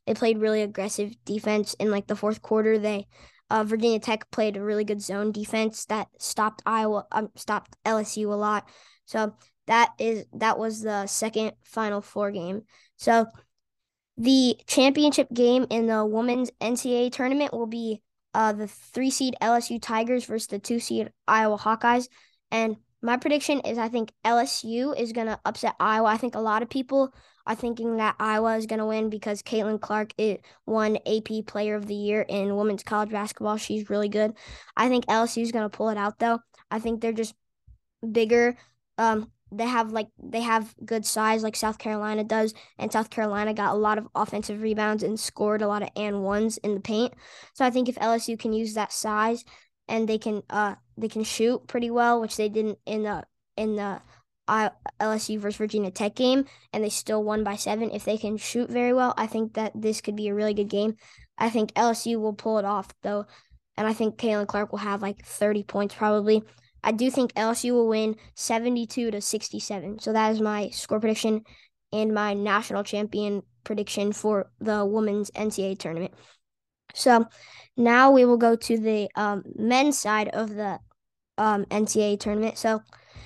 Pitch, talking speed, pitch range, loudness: 220 Hz, 190 wpm, 210-230 Hz, -26 LUFS